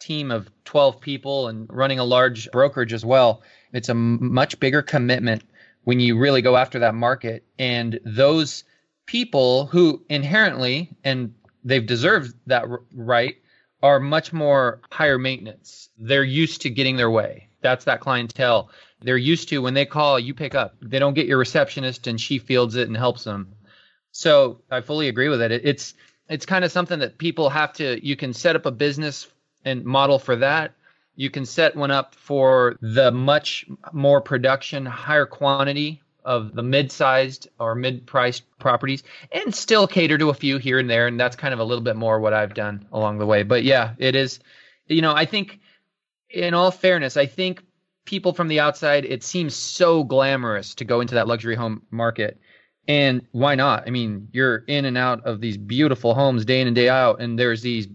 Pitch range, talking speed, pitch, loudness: 120-145 Hz, 190 wpm, 130 Hz, -20 LUFS